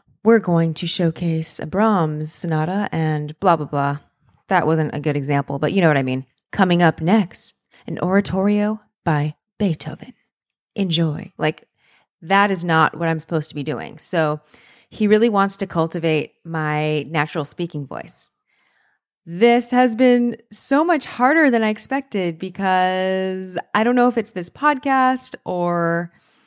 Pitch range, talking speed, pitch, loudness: 160-215 Hz, 155 wpm, 175 Hz, -19 LUFS